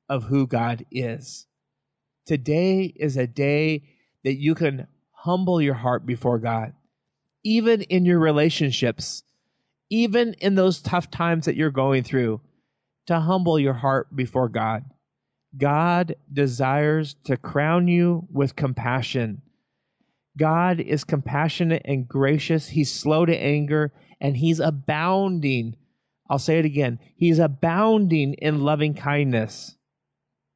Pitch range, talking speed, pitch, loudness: 135-165 Hz, 125 wpm, 150 Hz, -22 LUFS